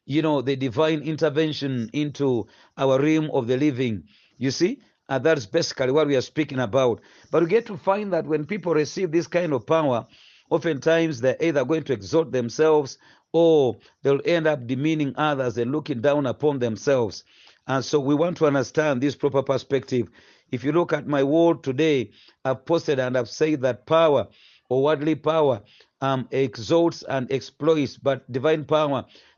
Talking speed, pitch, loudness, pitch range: 175 wpm, 150 Hz, -23 LUFS, 135-160 Hz